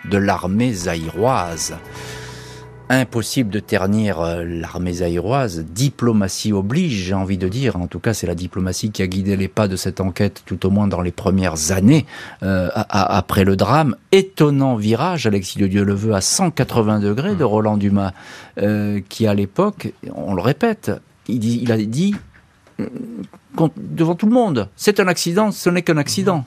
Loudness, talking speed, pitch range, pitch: -18 LUFS, 175 wpm, 95-135 Hz, 105 Hz